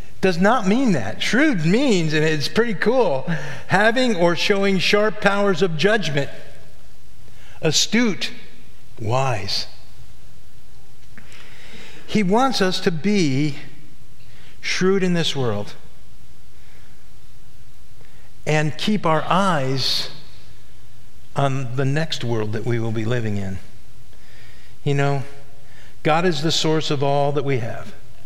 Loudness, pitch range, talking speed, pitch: -20 LUFS, 120-185 Hz, 115 wpm, 140 Hz